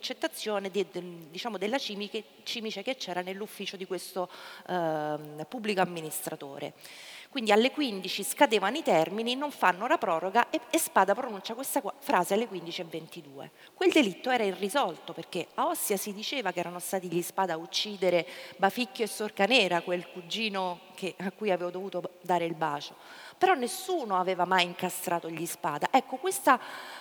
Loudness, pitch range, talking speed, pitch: -30 LUFS, 175-235 Hz, 150 wpm, 195 Hz